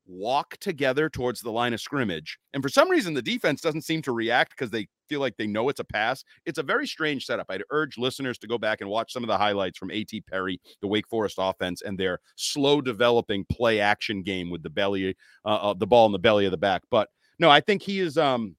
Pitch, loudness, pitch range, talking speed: 115 Hz, -25 LUFS, 100-145 Hz, 250 wpm